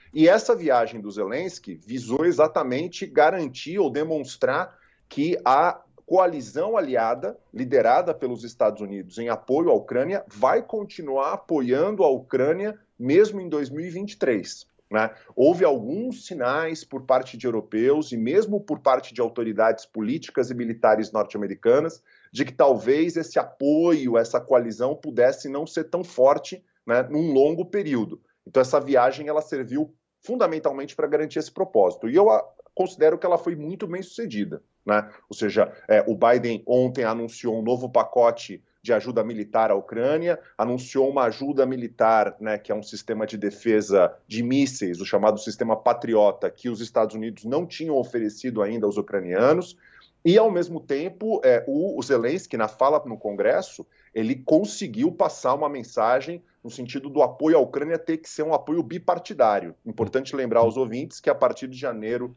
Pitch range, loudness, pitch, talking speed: 115-165 Hz, -23 LUFS, 130 Hz, 160 wpm